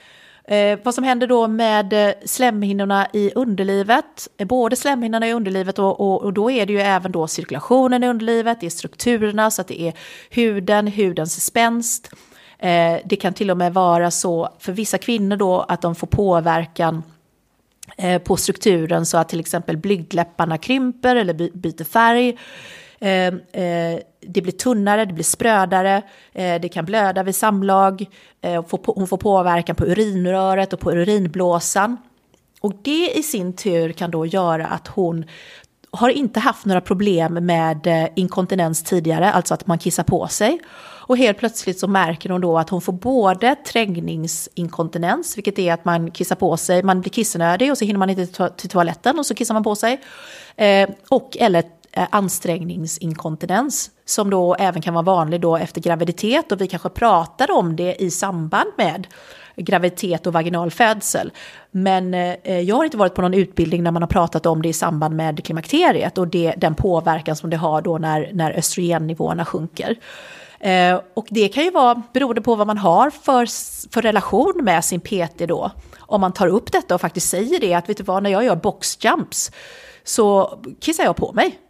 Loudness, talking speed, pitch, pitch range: -19 LUFS, 180 wpm, 190 Hz, 170-220 Hz